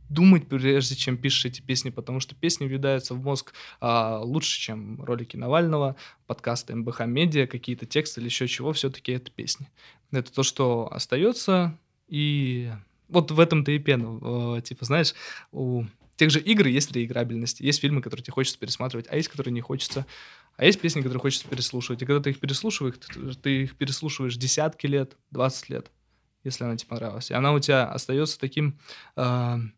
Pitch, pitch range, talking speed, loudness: 135 Hz, 120-145 Hz, 170 wpm, -25 LUFS